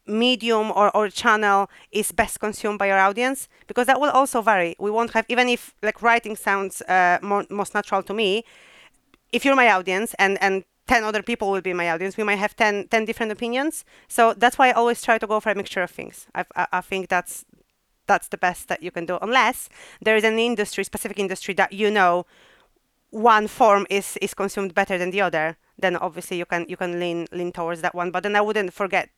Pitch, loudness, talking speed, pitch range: 205 Hz, -21 LUFS, 225 wpm, 185-225 Hz